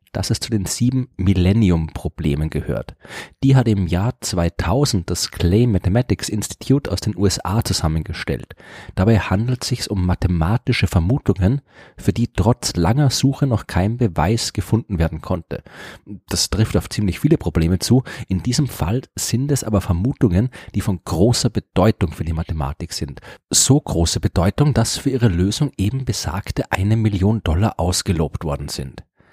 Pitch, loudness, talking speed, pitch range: 100 Hz, -19 LUFS, 155 wpm, 90-120 Hz